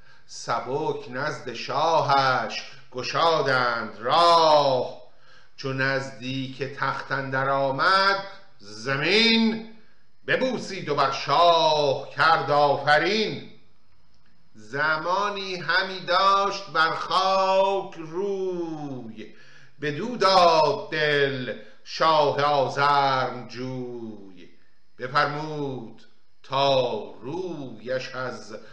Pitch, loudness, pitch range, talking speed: 145 Hz, -23 LUFS, 130-185 Hz, 70 wpm